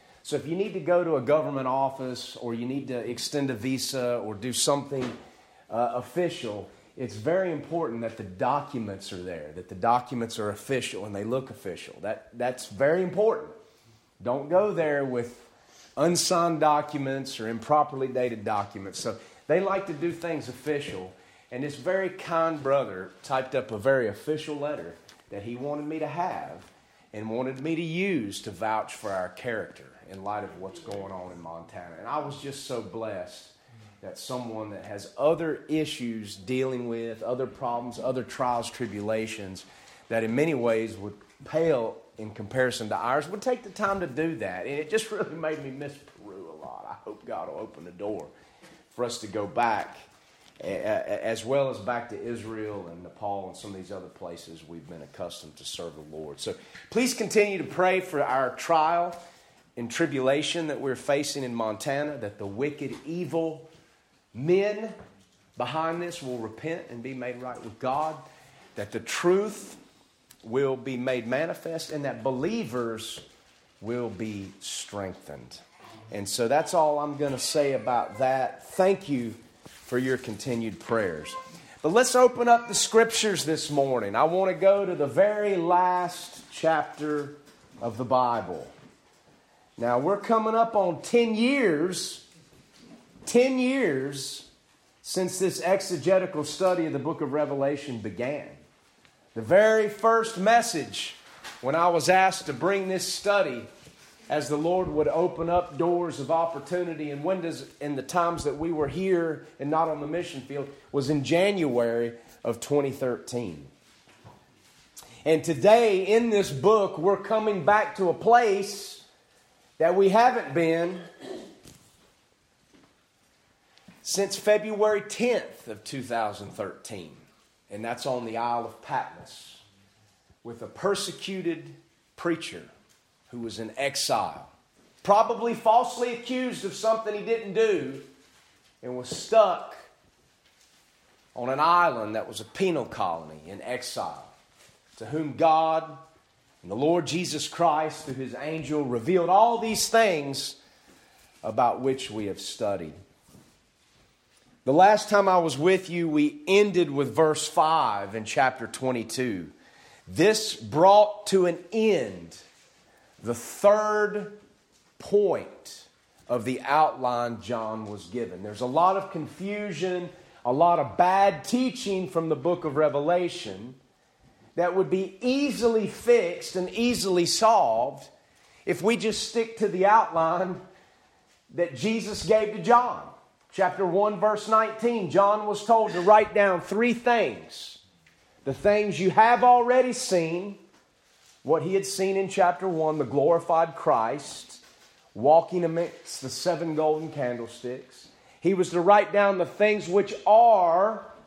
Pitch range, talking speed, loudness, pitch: 125-190 Hz, 145 wpm, -26 LUFS, 155 Hz